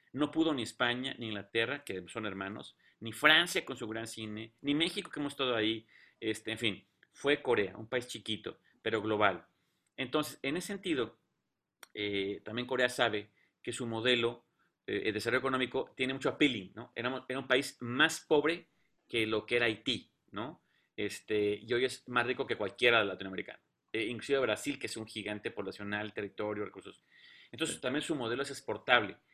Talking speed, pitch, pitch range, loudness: 180 wpm, 120 Hz, 110-135 Hz, -33 LUFS